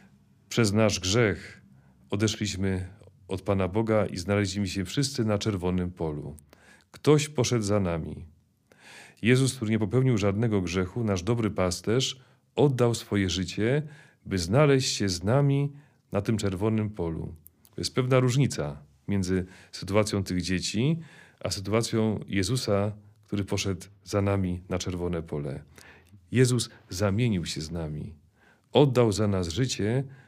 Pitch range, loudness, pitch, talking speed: 95-120 Hz, -27 LUFS, 100 Hz, 130 wpm